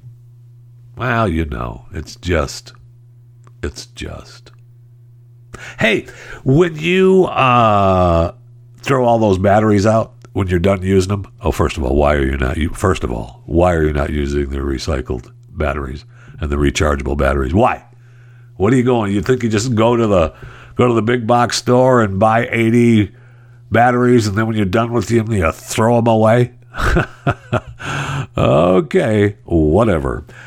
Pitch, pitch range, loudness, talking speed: 115 Hz, 90-120 Hz, -15 LUFS, 160 wpm